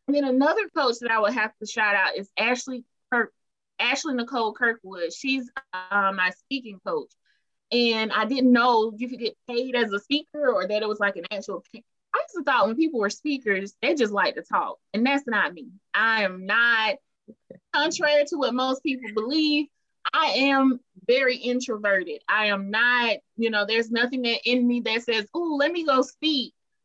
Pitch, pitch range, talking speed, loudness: 245 Hz, 215-275 Hz, 195 wpm, -24 LUFS